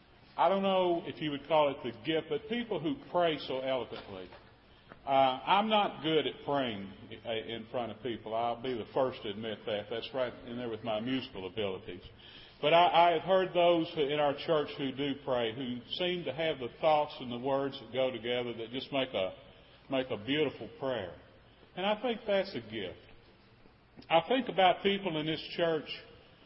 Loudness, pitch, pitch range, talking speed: -32 LUFS, 145 Hz, 120-170 Hz, 195 wpm